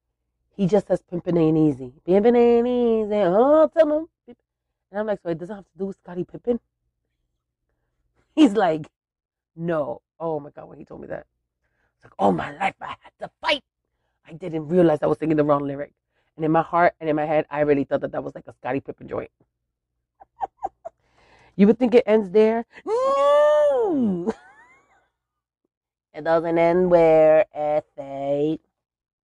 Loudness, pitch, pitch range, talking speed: -21 LUFS, 165 Hz, 145-215 Hz, 170 wpm